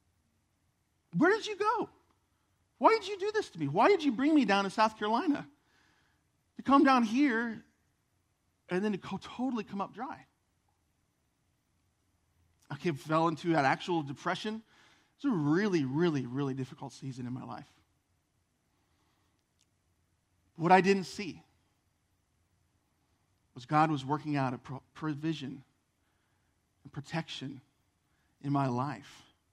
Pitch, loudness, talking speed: 140 Hz, -31 LUFS, 130 wpm